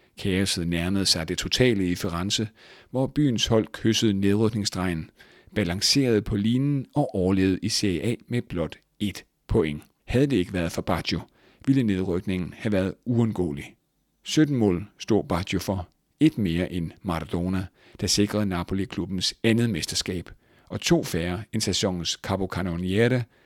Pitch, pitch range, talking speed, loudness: 100 Hz, 90-110 Hz, 145 wpm, -25 LUFS